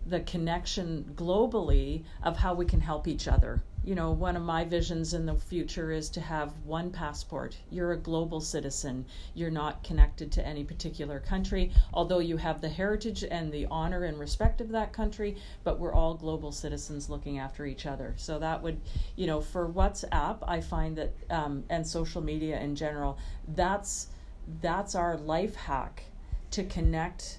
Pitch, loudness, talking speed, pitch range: 165 Hz, -33 LUFS, 175 wpm, 150-175 Hz